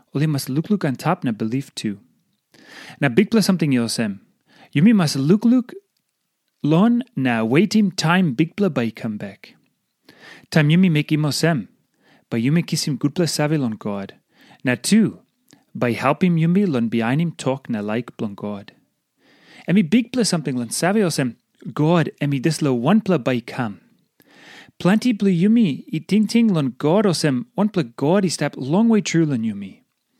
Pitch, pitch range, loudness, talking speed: 160 Hz, 130-195 Hz, -19 LUFS, 185 wpm